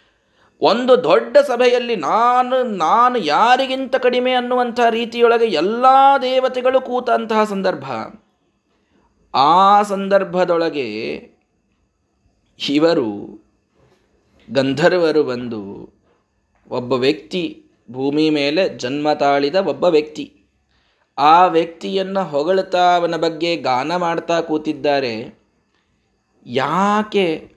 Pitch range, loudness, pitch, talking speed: 150-245 Hz, -16 LUFS, 180 Hz, 75 wpm